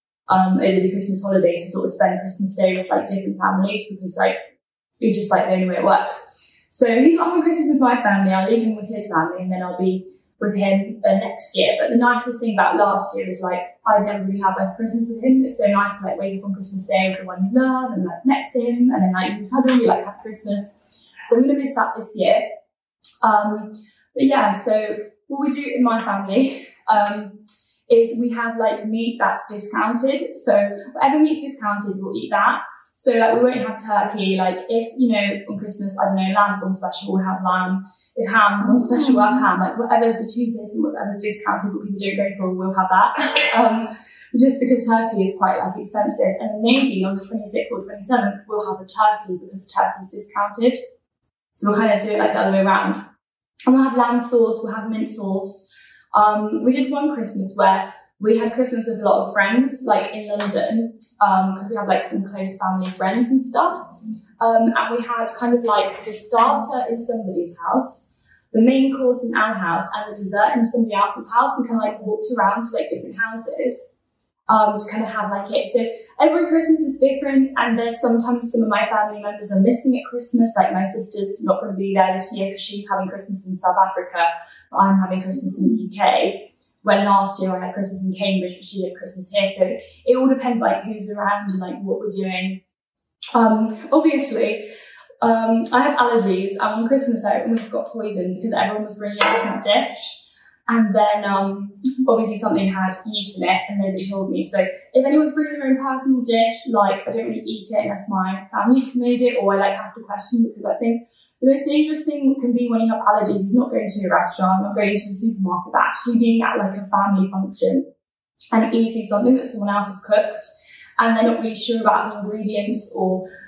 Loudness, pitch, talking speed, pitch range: -19 LUFS, 215 Hz, 220 wpm, 195-240 Hz